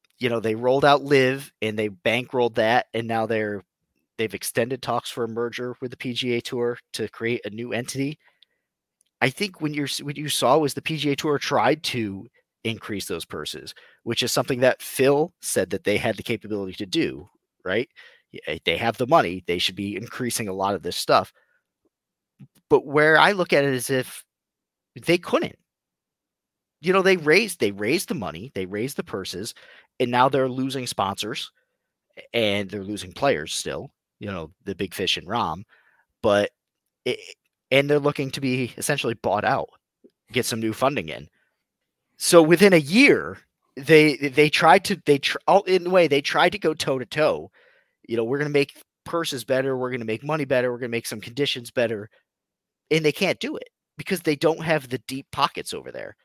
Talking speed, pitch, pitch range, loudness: 190 wpm, 130 Hz, 115-150 Hz, -23 LUFS